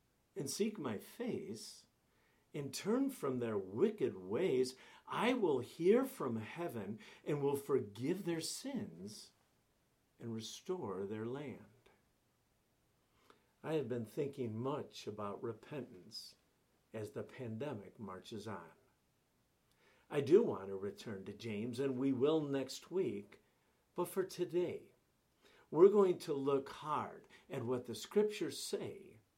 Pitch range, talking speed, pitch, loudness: 115-190 Hz, 125 wpm, 140 Hz, -39 LUFS